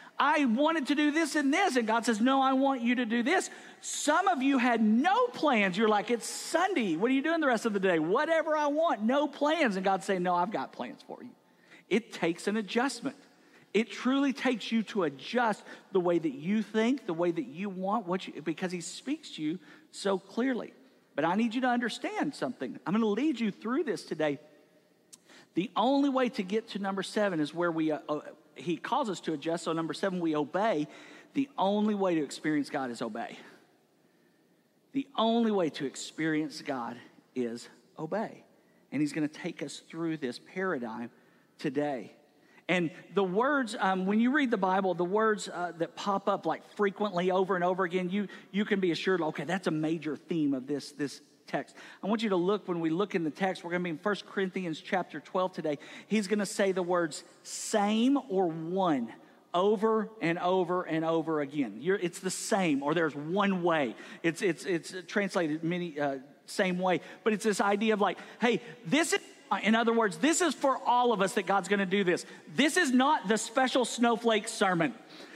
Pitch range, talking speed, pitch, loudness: 170-240 Hz, 205 wpm, 200 Hz, -30 LUFS